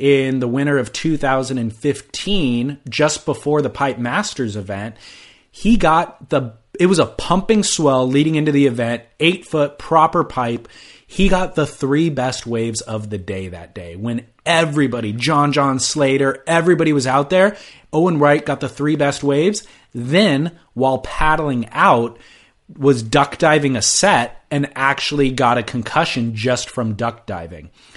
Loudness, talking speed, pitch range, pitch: -17 LUFS, 155 wpm, 120-155 Hz, 140 Hz